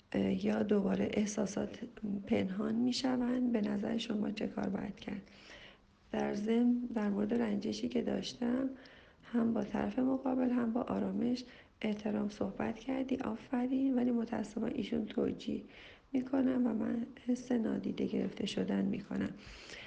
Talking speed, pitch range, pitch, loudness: 130 wpm, 215-250 Hz, 230 Hz, -35 LUFS